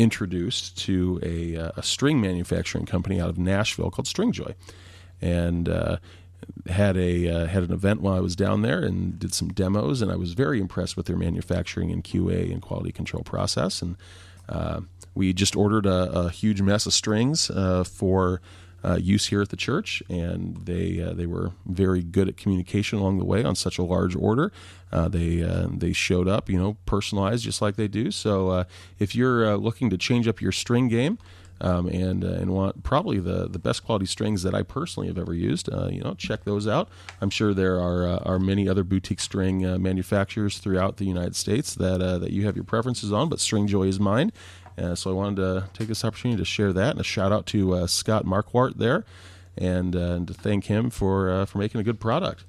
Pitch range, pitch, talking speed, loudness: 90-105 Hz, 95 Hz, 215 wpm, -25 LUFS